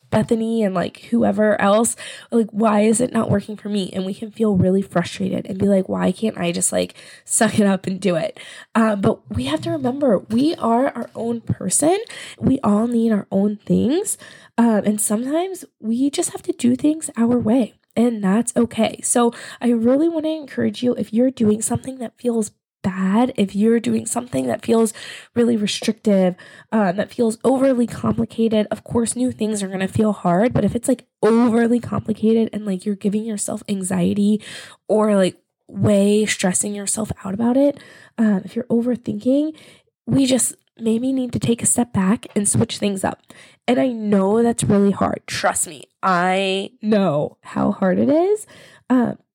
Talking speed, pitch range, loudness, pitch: 185 wpm, 200-240 Hz, -19 LUFS, 220 Hz